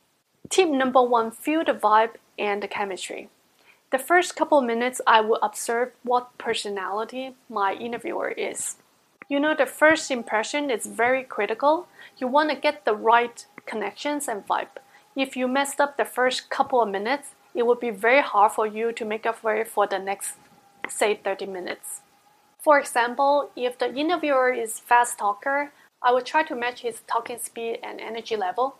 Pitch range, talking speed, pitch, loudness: 225-280 Hz, 175 wpm, 245 Hz, -24 LUFS